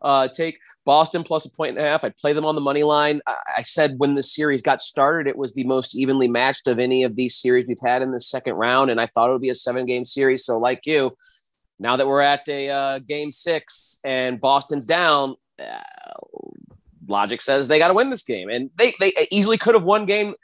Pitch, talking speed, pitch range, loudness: 140 Hz, 240 wpm, 130-165 Hz, -20 LUFS